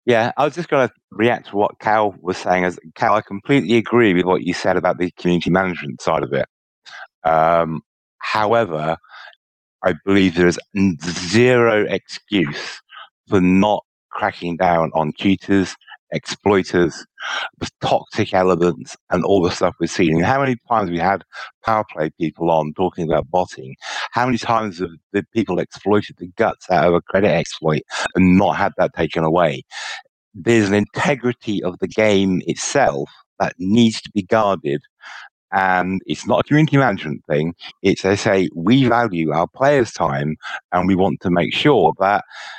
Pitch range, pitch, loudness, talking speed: 85-110 Hz, 95 Hz, -18 LUFS, 170 wpm